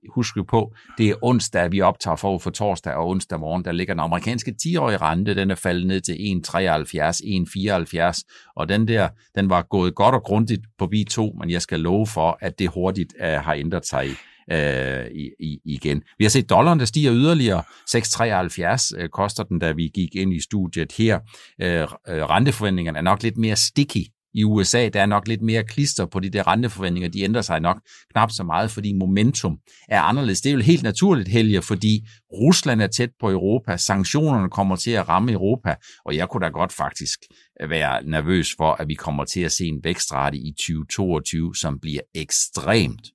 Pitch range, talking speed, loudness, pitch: 85-115 Hz, 195 wpm, -21 LUFS, 100 Hz